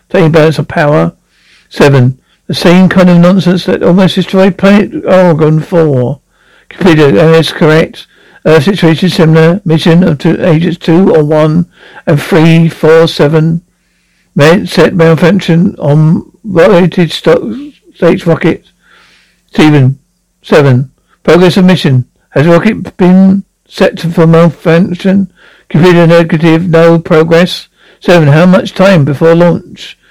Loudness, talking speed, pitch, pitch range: -6 LUFS, 130 wpm, 170 Hz, 160-185 Hz